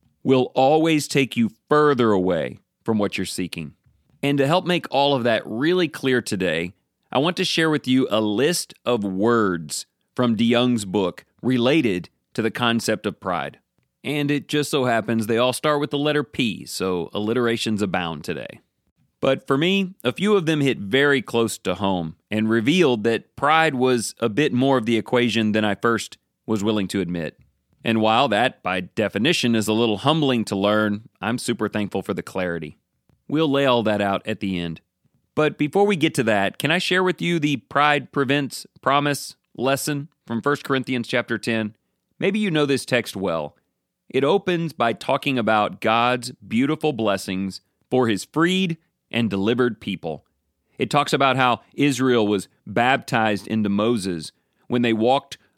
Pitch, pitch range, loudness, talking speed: 120 Hz, 105-145 Hz, -21 LUFS, 175 wpm